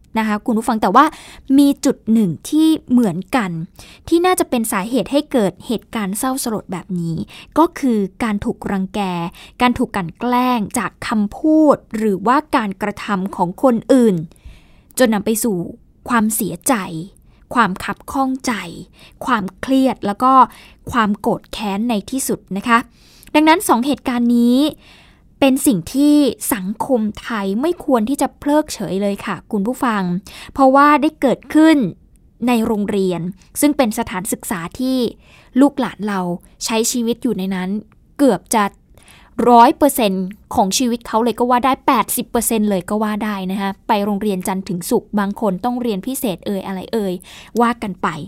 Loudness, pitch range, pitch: -17 LUFS, 200-260 Hz, 230 Hz